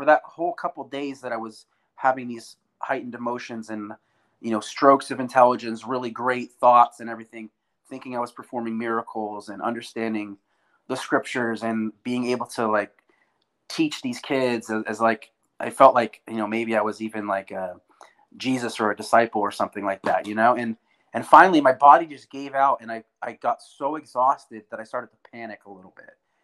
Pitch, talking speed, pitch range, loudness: 115 Hz, 195 wpm, 110-130 Hz, -23 LUFS